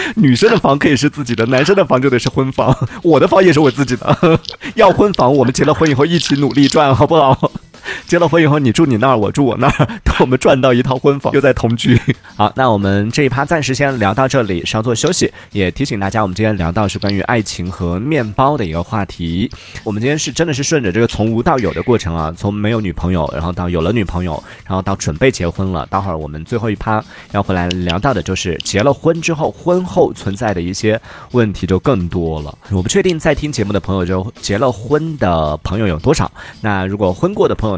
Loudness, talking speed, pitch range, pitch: -14 LUFS, 355 characters per minute, 95-140 Hz, 115 Hz